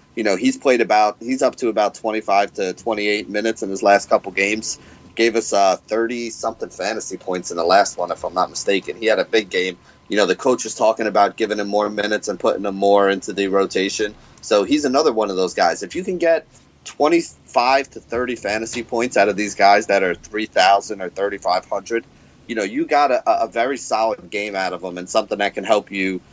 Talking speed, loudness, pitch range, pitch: 225 wpm, -19 LUFS, 100-115 Hz, 105 Hz